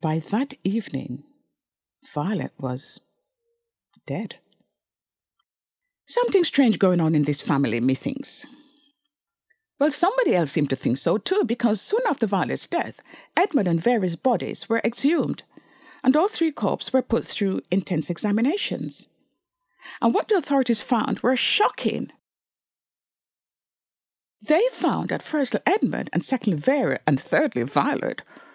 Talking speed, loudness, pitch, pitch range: 125 wpm, -23 LUFS, 260 Hz, 195-325 Hz